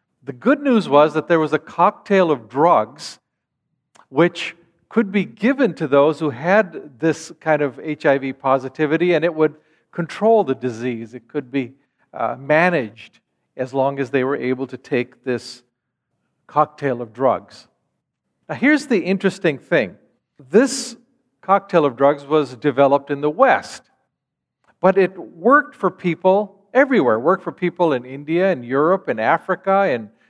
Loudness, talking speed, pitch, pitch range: -19 LUFS, 155 wpm, 155 Hz, 135-190 Hz